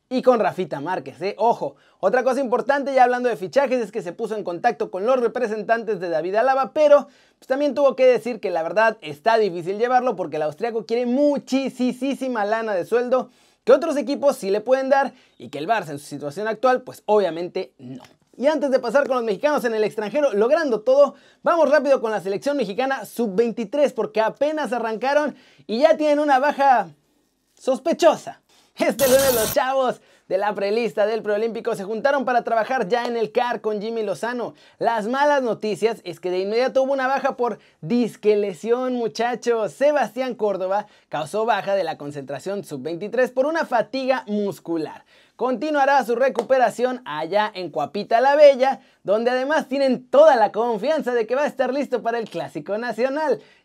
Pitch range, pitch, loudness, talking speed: 210-270 Hz, 240 Hz, -21 LUFS, 180 wpm